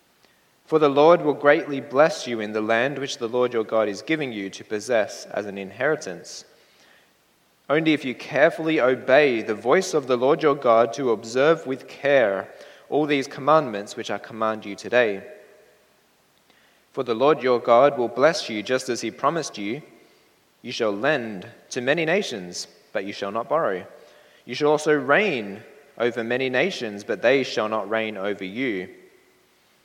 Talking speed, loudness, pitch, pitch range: 170 wpm, -22 LUFS, 125 Hz, 110-145 Hz